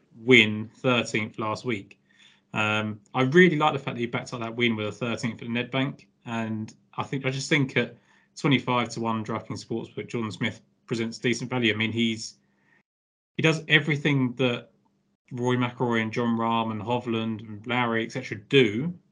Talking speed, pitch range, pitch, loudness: 180 wpm, 110-130 Hz, 120 Hz, -26 LUFS